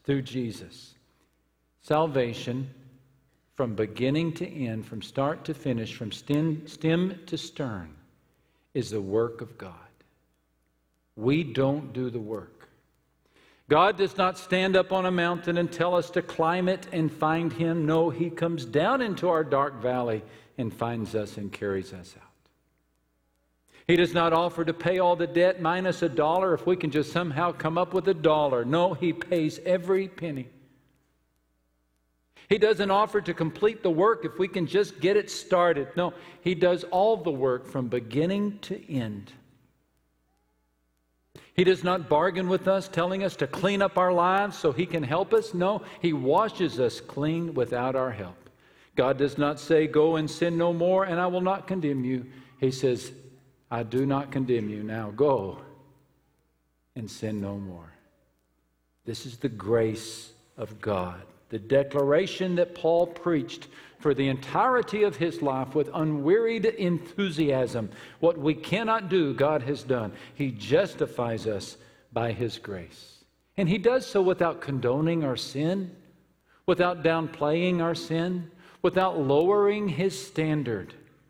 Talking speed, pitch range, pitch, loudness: 155 wpm, 120-175 Hz, 150 Hz, -27 LUFS